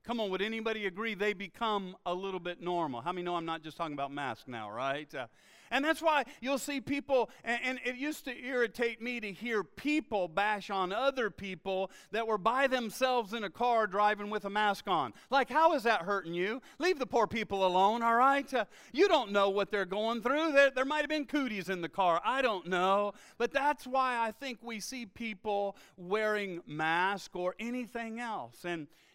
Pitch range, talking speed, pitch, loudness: 195-255 Hz, 210 wpm, 220 Hz, -32 LUFS